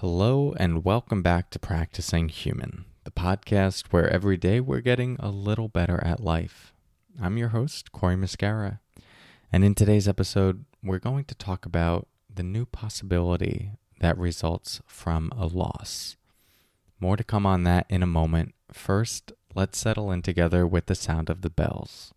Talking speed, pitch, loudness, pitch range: 160 wpm, 95 Hz, -26 LUFS, 85-105 Hz